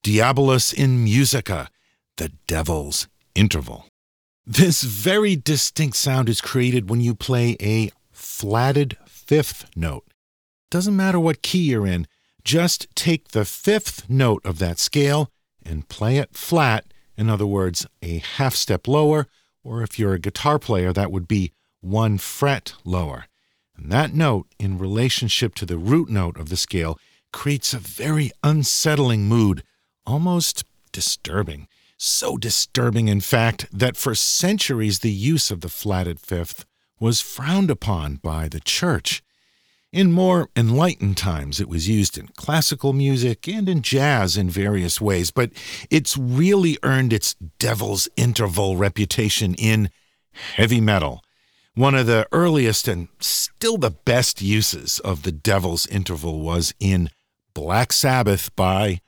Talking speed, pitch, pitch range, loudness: 140 wpm, 110 Hz, 95-135 Hz, -20 LUFS